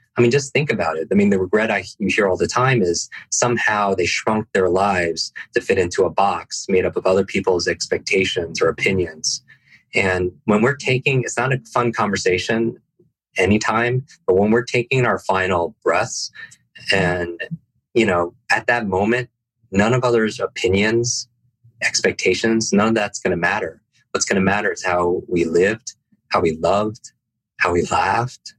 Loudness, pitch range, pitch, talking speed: -19 LUFS, 100-120 Hz, 115 Hz, 170 wpm